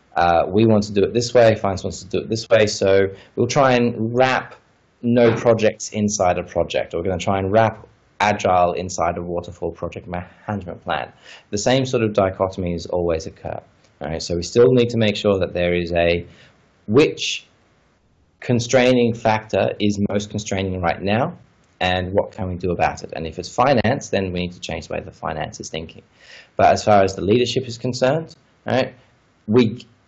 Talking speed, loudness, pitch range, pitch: 200 wpm, -20 LUFS, 90-120 Hz, 105 Hz